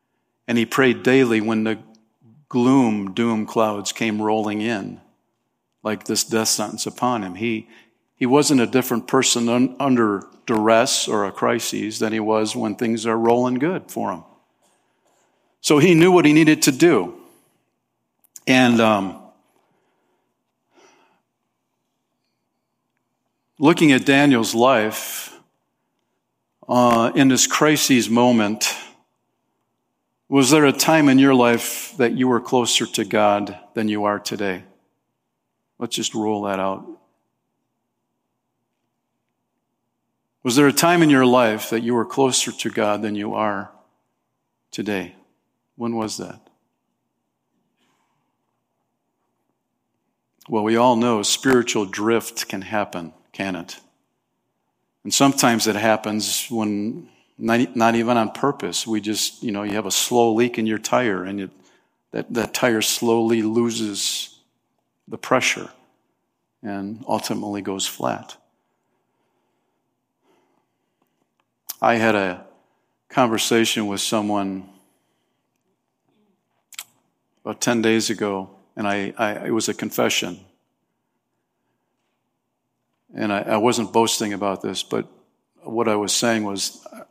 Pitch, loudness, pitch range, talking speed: 115 Hz, -19 LUFS, 105-120 Hz, 120 wpm